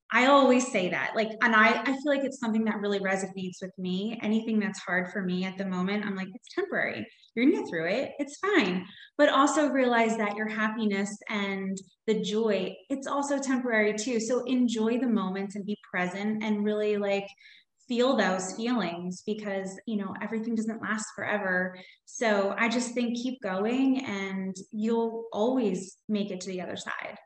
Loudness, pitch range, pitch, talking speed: -28 LUFS, 195-245 Hz, 215 Hz, 185 wpm